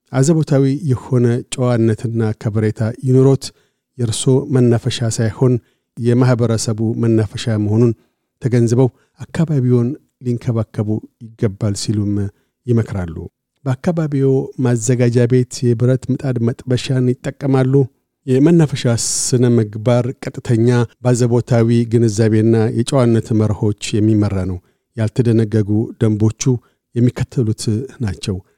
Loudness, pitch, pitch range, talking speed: -16 LUFS, 120 Hz, 110-130 Hz, 80 wpm